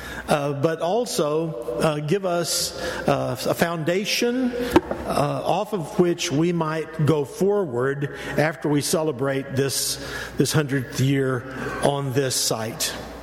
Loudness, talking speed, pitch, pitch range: -23 LUFS, 120 wpm, 155 Hz, 140-175 Hz